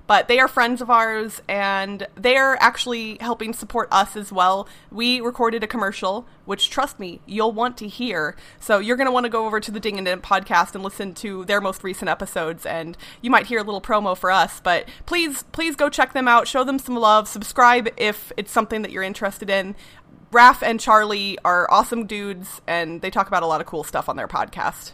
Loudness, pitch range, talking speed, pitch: -20 LUFS, 195-240 Hz, 220 wpm, 215 Hz